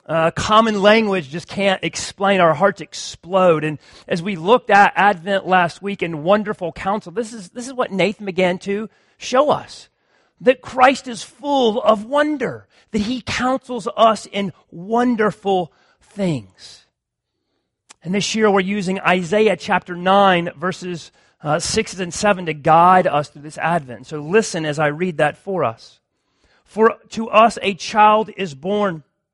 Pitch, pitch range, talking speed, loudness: 195 Hz, 175-215 Hz, 160 wpm, -18 LUFS